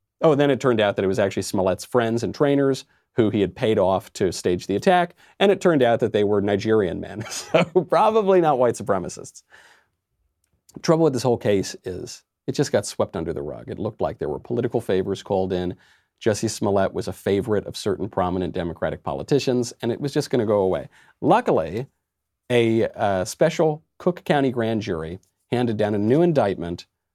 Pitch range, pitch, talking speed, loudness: 95-145 Hz, 115 Hz, 200 wpm, -22 LUFS